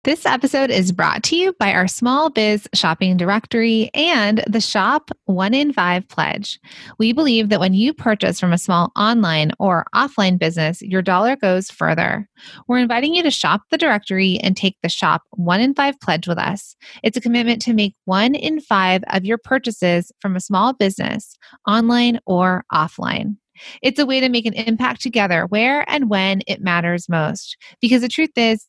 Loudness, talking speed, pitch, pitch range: -17 LUFS, 185 wpm, 215 Hz, 190-250 Hz